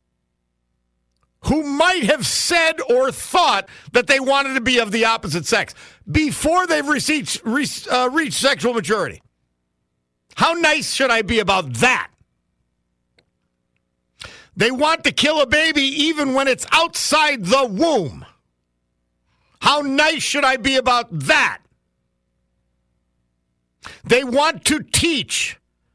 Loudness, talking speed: -17 LUFS, 125 wpm